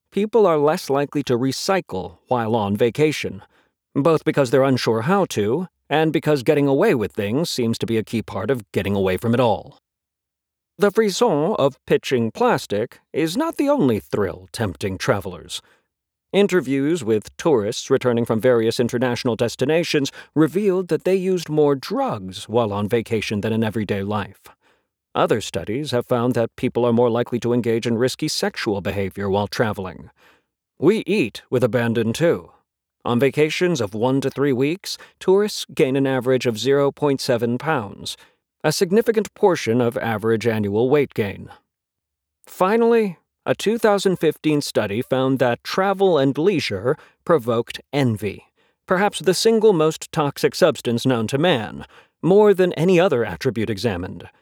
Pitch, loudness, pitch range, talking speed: 130 Hz, -20 LUFS, 115-160 Hz, 150 wpm